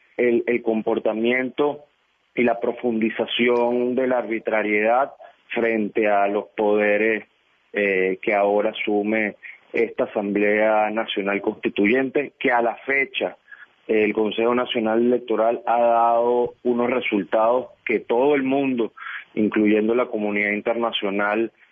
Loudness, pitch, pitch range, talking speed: -21 LUFS, 115 Hz, 105-120 Hz, 115 wpm